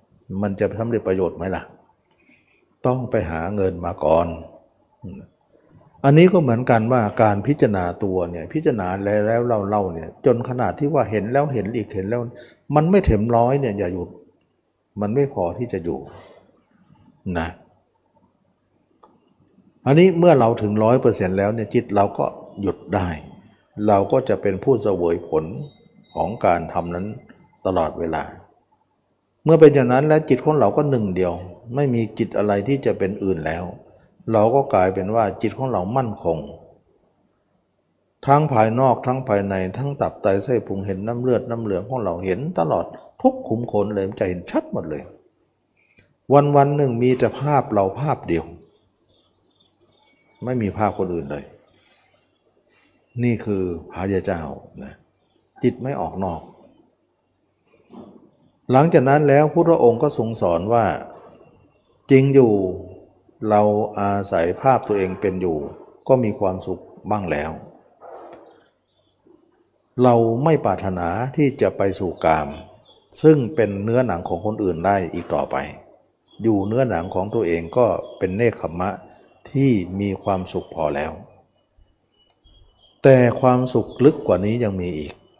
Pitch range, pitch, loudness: 95-125 Hz, 105 Hz, -20 LUFS